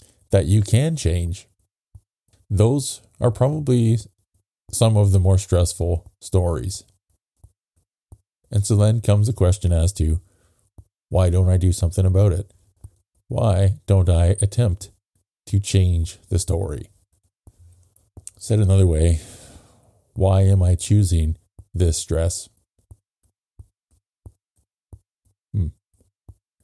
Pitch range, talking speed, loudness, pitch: 90-105 Hz, 105 wpm, -20 LUFS, 95 Hz